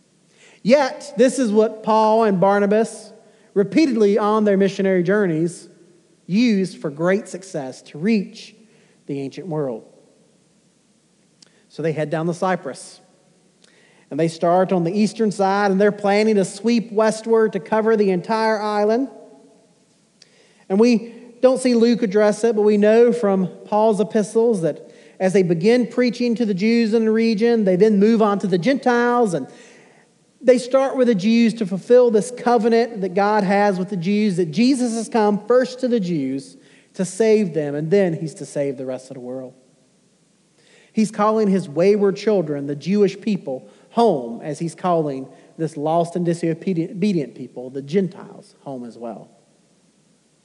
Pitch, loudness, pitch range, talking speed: 205 Hz, -19 LUFS, 175-225 Hz, 160 wpm